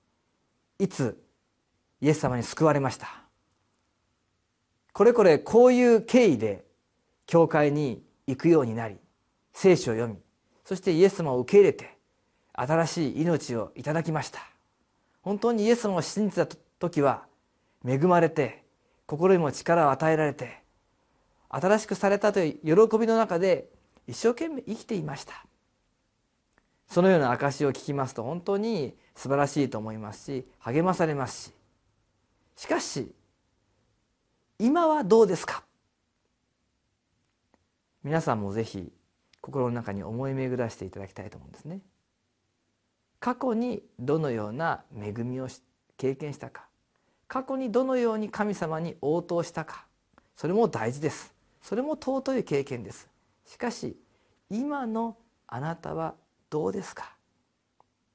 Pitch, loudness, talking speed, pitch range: 150 Hz, -26 LUFS, 260 characters per minute, 120-200 Hz